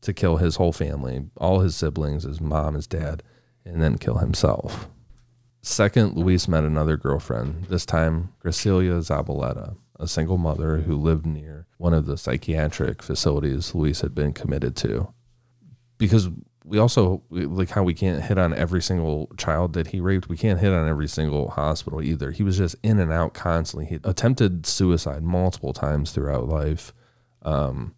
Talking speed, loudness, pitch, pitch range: 170 wpm, -23 LUFS, 85 Hz, 75-95 Hz